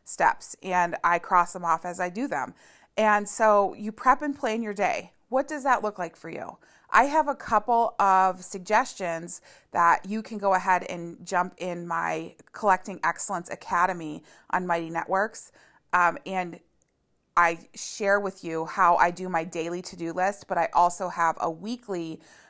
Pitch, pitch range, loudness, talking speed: 185 Hz, 170-210 Hz, -26 LUFS, 175 wpm